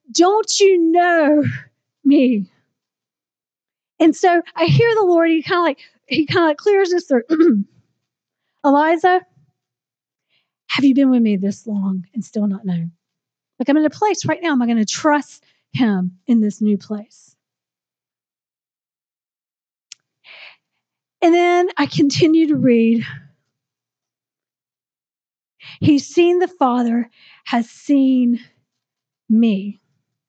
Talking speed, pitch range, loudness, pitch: 125 wpm, 205-330 Hz, -16 LUFS, 260 Hz